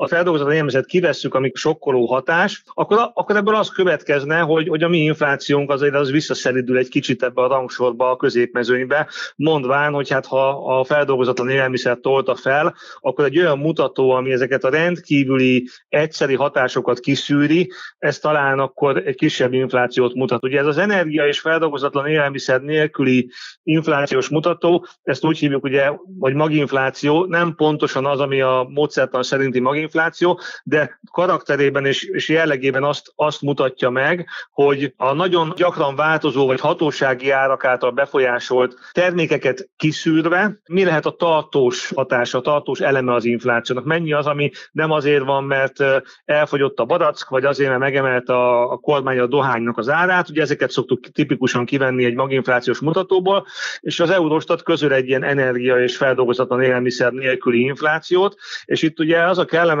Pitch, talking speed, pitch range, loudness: 145 Hz, 160 wpm, 130-160 Hz, -18 LUFS